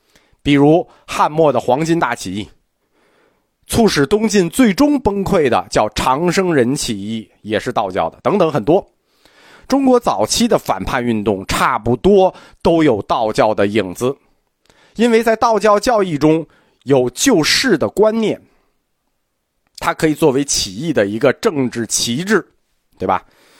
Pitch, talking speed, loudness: 155 Hz, 210 characters per minute, -15 LUFS